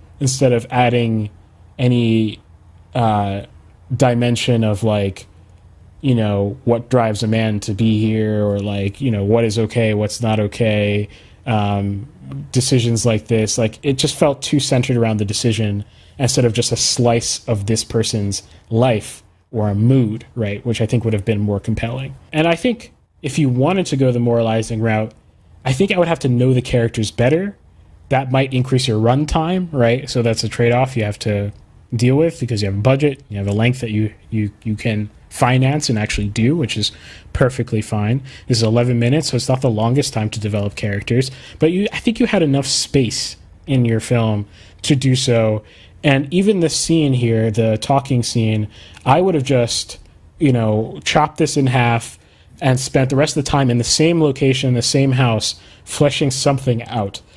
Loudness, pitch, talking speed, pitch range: -17 LUFS, 115 Hz, 190 wpm, 105-130 Hz